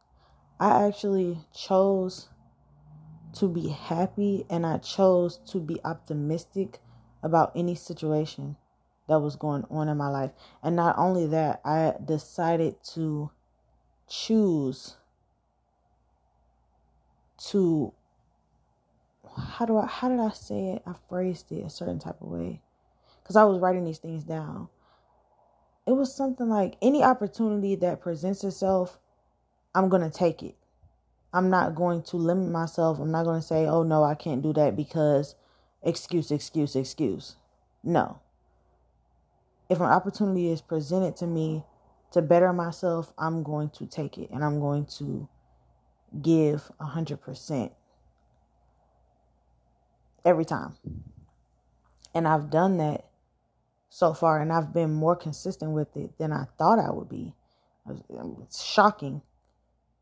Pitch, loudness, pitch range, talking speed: 160 Hz, -27 LUFS, 145-180 Hz, 135 wpm